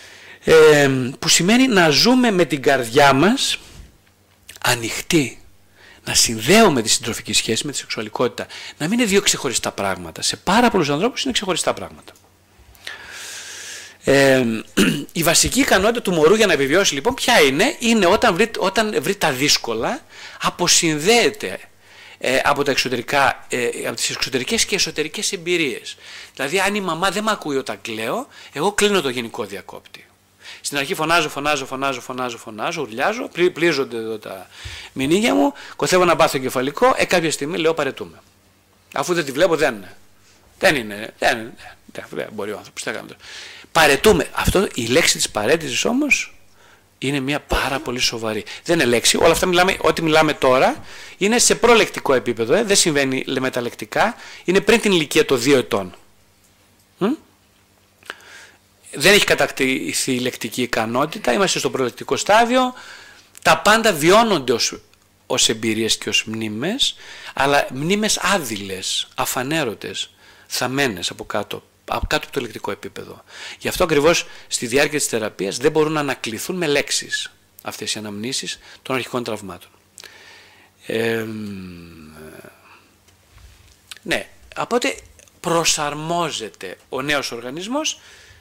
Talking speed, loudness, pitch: 145 wpm, -18 LUFS, 145 Hz